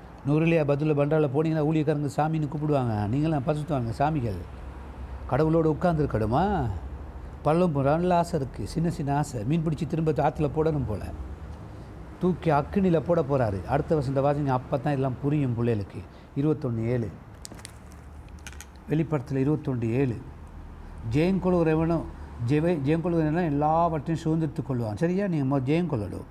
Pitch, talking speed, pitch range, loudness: 145 Hz, 120 wpm, 115-160 Hz, -26 LUFS